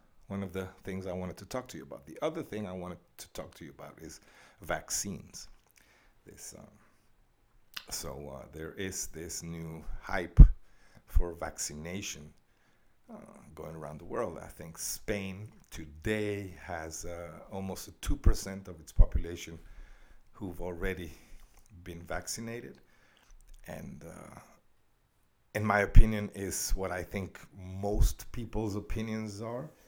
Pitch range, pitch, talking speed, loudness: 85-105 Hz, 95 Hz, 135 wpm, -35 LUFS